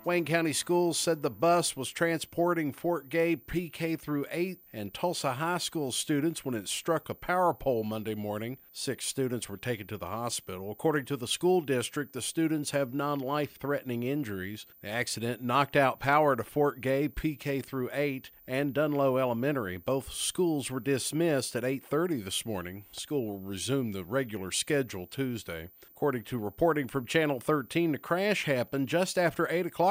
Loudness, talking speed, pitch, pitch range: -30 LUFS, 170 wpm, 140 Hz, 120-160 Hz